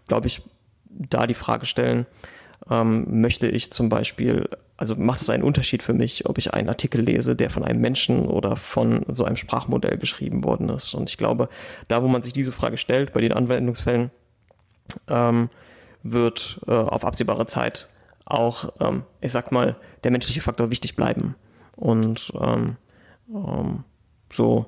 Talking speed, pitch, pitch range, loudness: 165 wpm, 115 Hz, 110-125 Hz, -23 LUFS